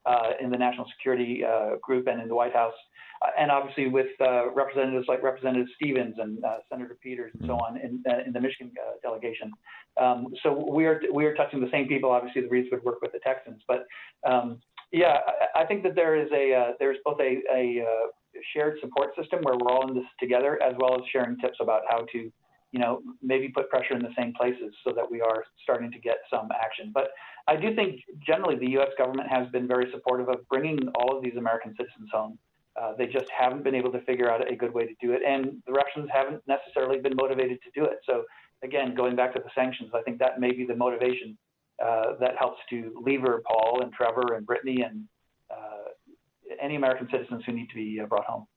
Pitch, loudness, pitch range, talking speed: 125 Hz, -27 LUFS, 120-135 Hz, 225 wpm